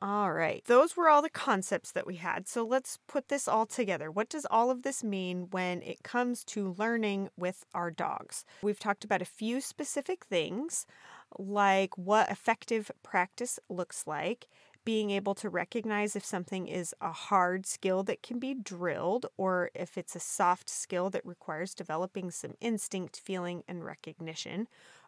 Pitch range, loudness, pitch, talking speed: 180-230 Hz, -32 LUFS, 195 Hz, 170 wpm